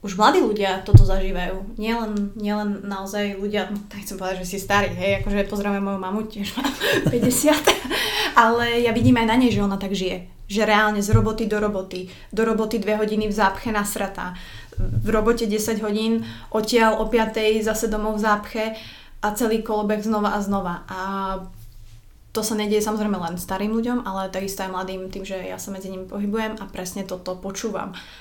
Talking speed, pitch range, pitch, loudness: 185 wpm, 190-220 Hz, 205 Hz, -22 LUFS